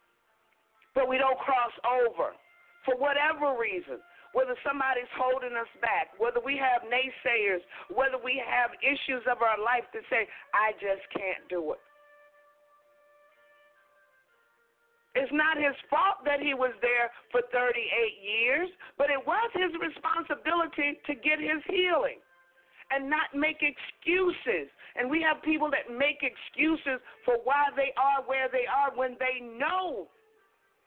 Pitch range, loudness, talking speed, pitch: 250-315 Hz, -29 LUFS, 140 wpm, 280 Hz